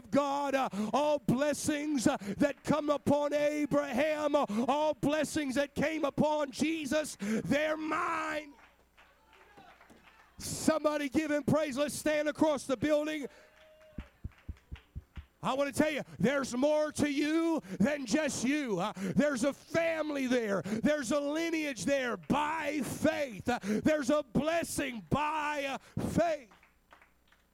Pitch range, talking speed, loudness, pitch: 270-300 Hz, 120 wpm, -32 LUFS, 290 Hz